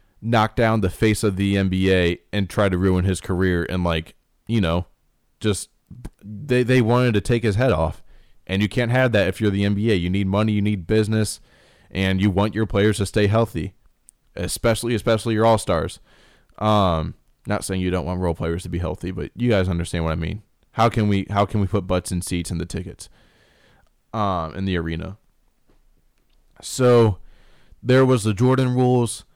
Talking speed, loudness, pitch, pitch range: 190 wpm, -21 LUFS, 100 Hz, 90-110 Hz